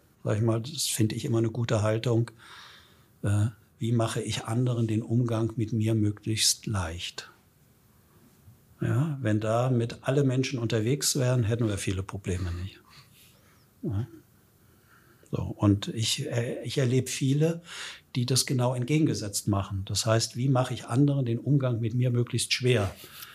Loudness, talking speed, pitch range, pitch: -28 LUFS, 150 wpm, 110-125 Hz, 115 Hz